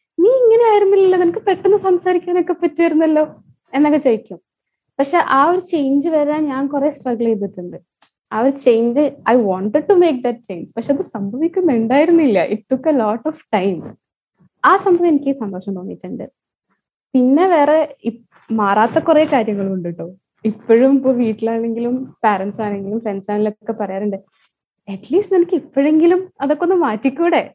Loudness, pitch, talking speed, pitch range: -16 LUFS, 275 Hz, 135 wpm, 215-330 Hz